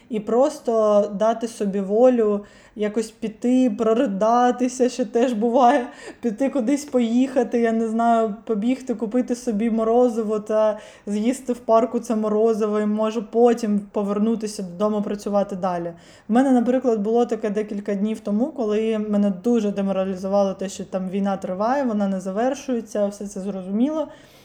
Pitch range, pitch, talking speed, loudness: 210-240 Hz, 225 Hz, 140 wpm, -21 LUFS